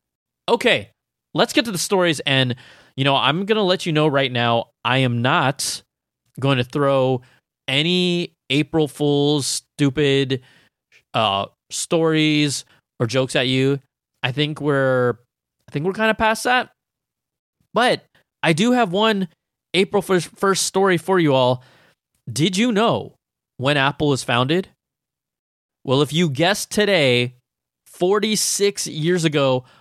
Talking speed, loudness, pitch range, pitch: 135 wpm, -19 LUFS, 130-180 Hz, 150 Hz